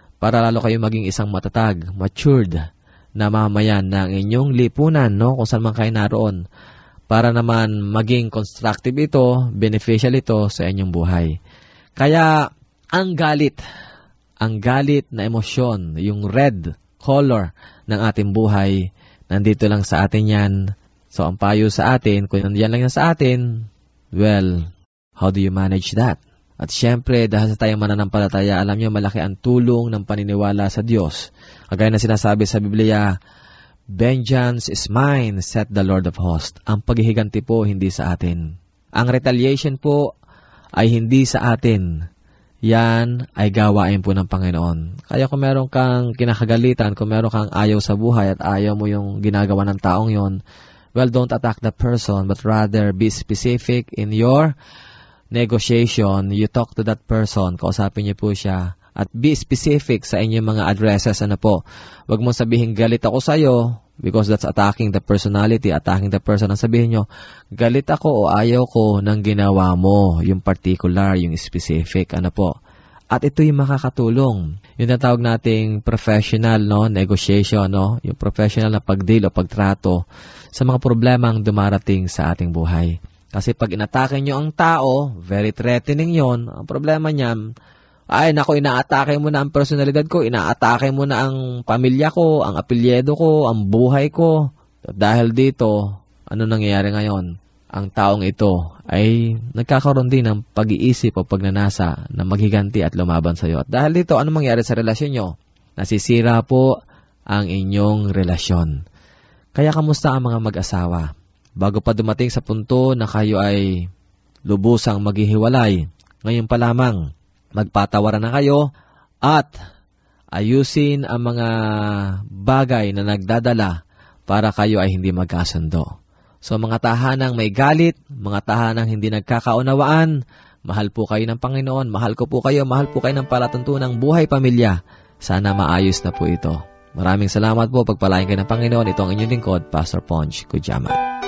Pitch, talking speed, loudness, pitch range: 110 Hz, 150 wpm, -17 LUFS, 100-120 Hz